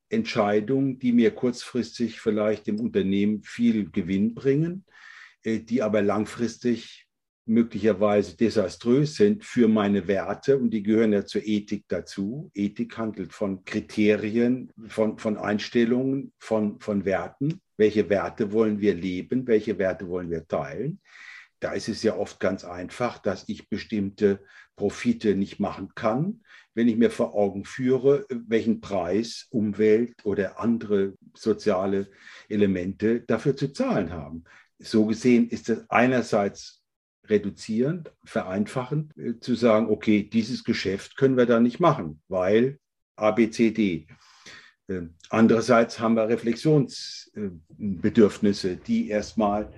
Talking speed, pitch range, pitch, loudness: 125 wpm, 105-120 Hz, 110 Hz, -25 LUFS